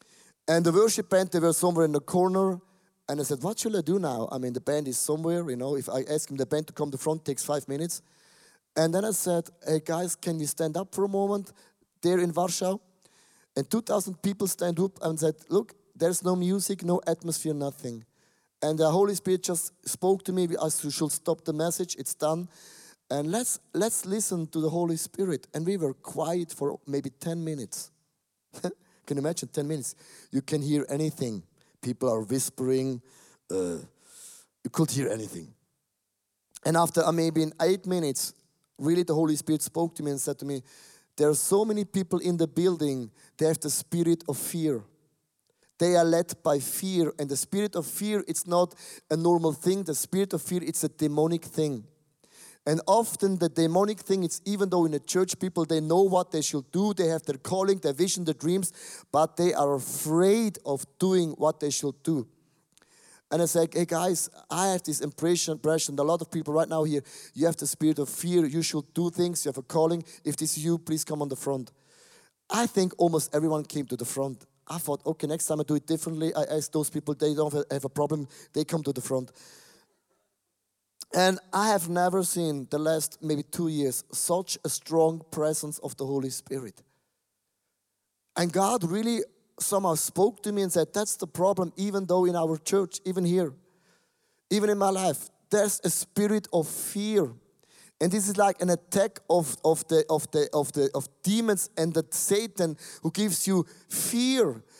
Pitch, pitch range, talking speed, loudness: 165 Hz, 150-185 Hz, 200 wpm, -28 LUFS